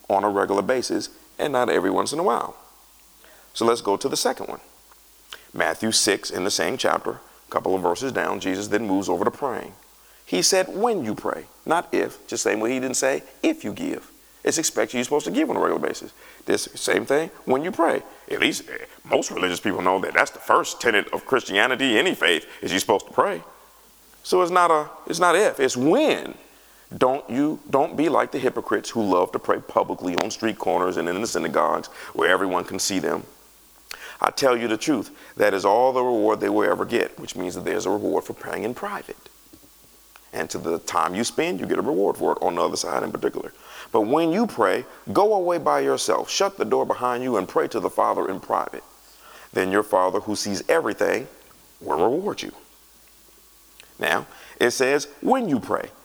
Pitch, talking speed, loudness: 170 Hz, 210 wpm, -23 LUFS